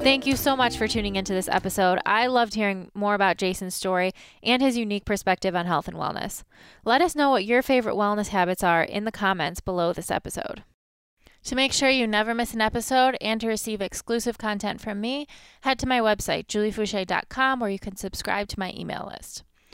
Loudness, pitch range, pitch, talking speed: -24 LUFS, 190-245 Hz, 210 Hz, 205 wpm